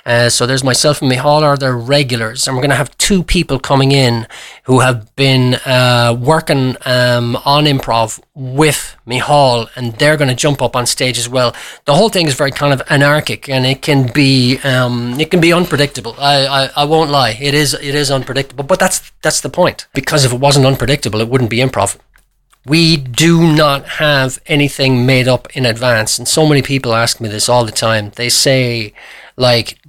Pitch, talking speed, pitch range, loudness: 135 Hz, 205 wpm, 125-145 Hz, -12 LUFS